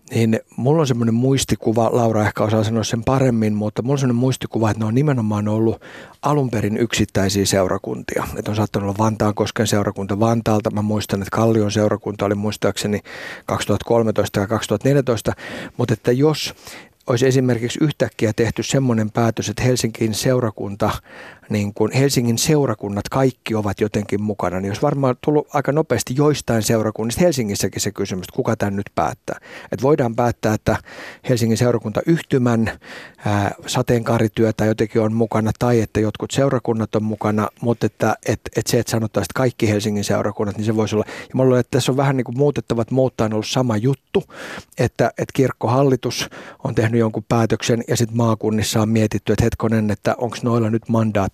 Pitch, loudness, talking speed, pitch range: 115 Hz, -19 LUFS, 165 wpm, 105-125 Hz